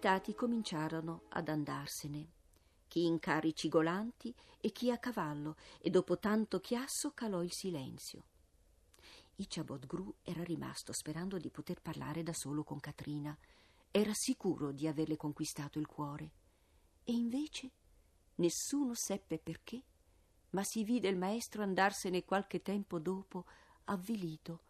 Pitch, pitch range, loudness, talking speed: 175 Hz, 150-205 Hz, -39 LUFS, 125 wpm